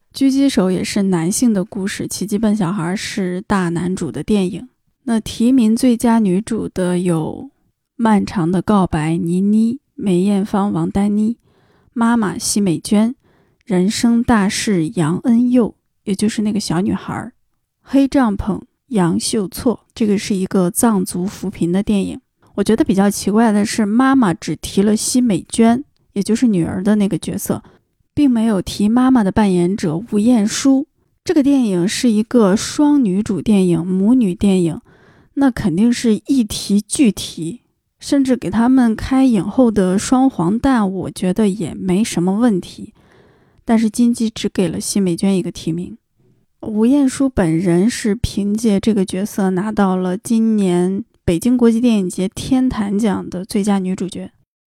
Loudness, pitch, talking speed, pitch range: -16 LUFS, 205 Hz, 235 characters per minute, 185-235 Hz